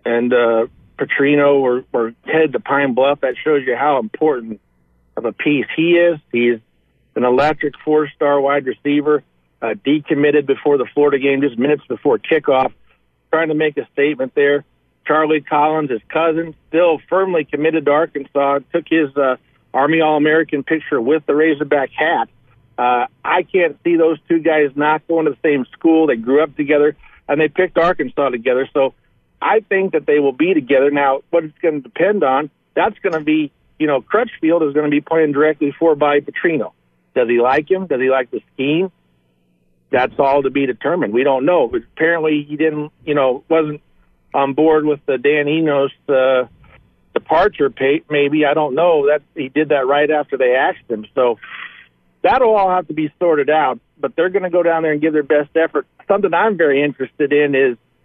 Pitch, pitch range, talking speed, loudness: 150 Hz, 135-160 Hz, 190 wpm, -16 LUFS